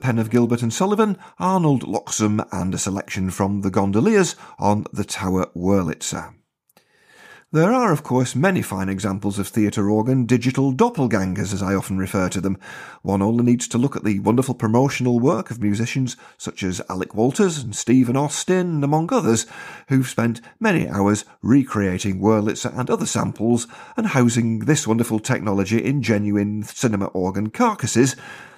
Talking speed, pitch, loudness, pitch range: 155 wpm, 115 Hz, -20 LUFS, 100-130 Hz